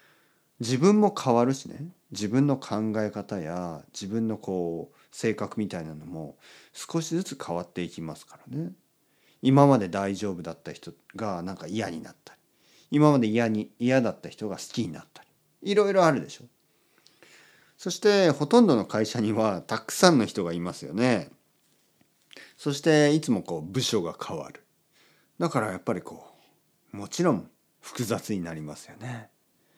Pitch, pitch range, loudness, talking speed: 115 Hz, 100-145 Hz, -26 LUFS, 300 characters per minute